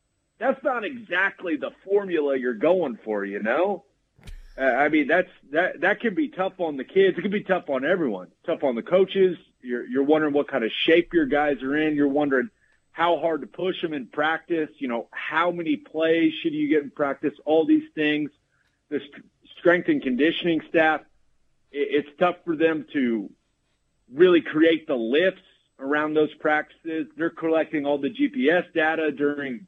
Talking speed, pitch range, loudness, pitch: 185 wpm, 145-185 Hz, -24 LUFS, 160 Hz